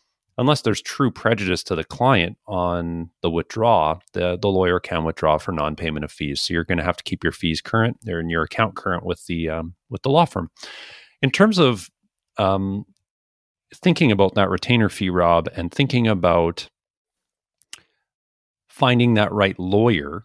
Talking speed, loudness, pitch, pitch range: 175 wpm, -20 LUFS, 90 Hz, 85-110 Hz